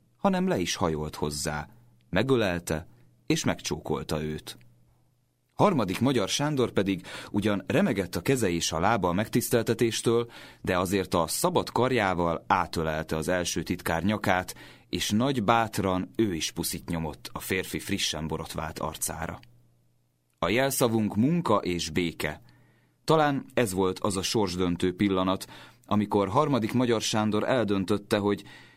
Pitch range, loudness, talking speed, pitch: 85-115 Hz, -27 LUFS, 130 wpm, 95 Hz